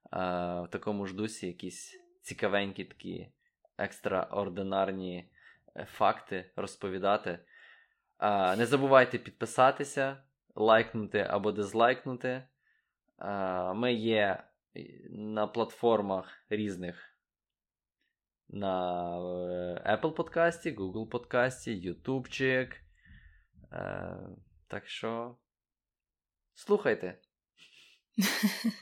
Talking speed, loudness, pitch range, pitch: 60 wpm, -32 LUFS, 95-130 Hz, 105 Hz